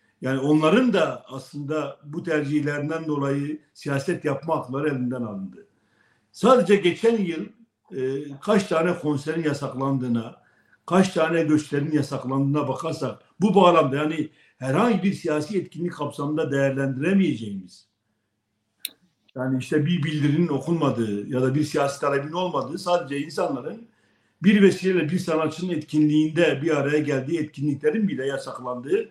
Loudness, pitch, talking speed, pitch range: -23 LUFS, 150 Hz, 120 wpm, 135-175 Hz